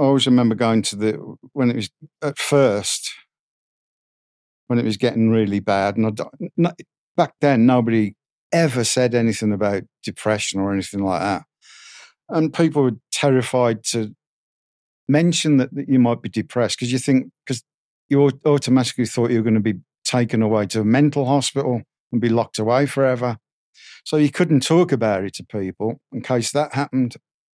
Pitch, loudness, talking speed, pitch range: 120 Hz, -20 LUFS, 170 wpm, 110-140 Hz